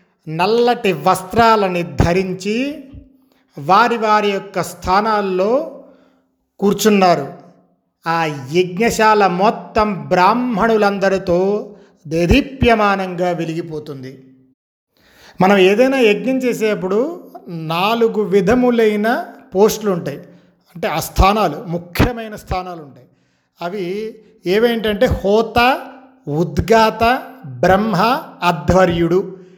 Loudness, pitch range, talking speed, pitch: -16 LUFS, 175-225 Hz, 70 wpm, 195 Hz